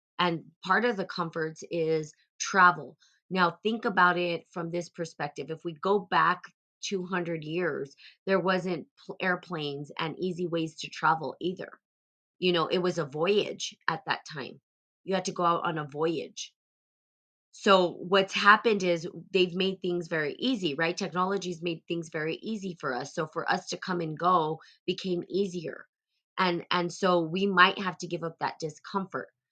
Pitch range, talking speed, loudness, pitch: 165-185 Hz, 170 wpm, -29 LUFS, 175 Hz